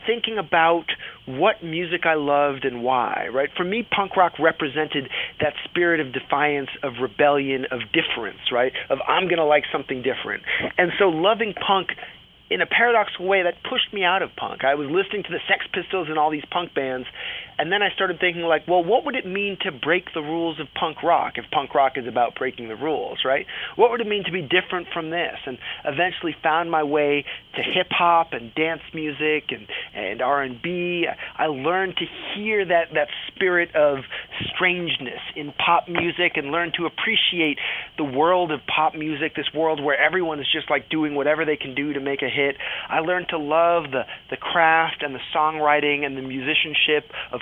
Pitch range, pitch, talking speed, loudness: 145-180 Hz, 160 Hz, 200 wpm, -22 LUFS